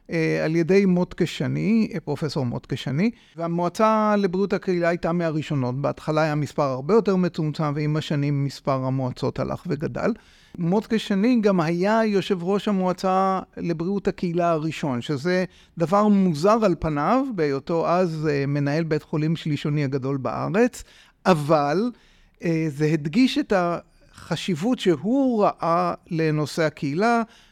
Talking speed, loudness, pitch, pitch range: 115 wpm, -23 LUFS, 170 Hz, 155-200 Hz